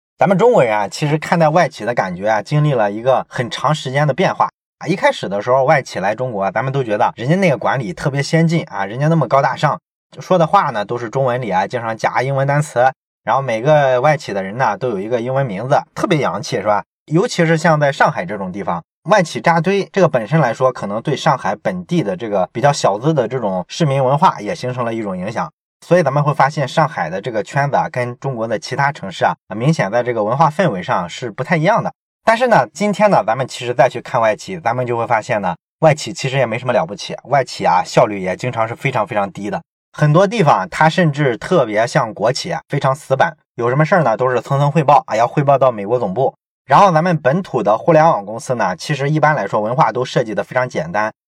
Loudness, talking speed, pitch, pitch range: -16 LUFS, 360 characters per minute, 145 Hz, 125-165 Hz